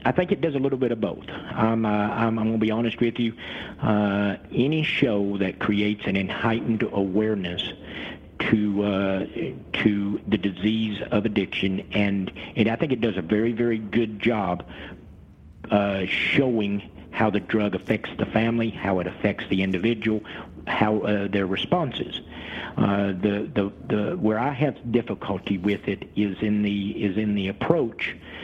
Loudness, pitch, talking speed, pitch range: -25 LUFS, 105 Hz, 165 wpm, 100-115 Hz